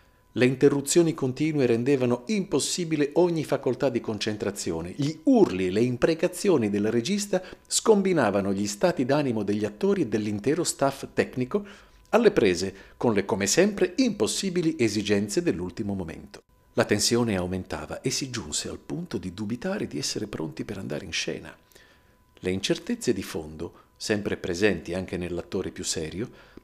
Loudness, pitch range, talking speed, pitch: -26 LUFS, 100-165 Hz, 140 wpm, 125 Hz